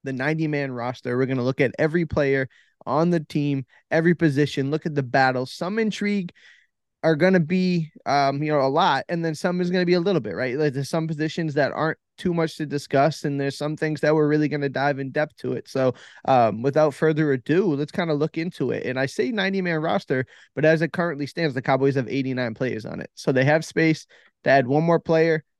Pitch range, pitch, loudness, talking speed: 135-165 Hz, 150 Hz, -23 LUFS, 235 wpm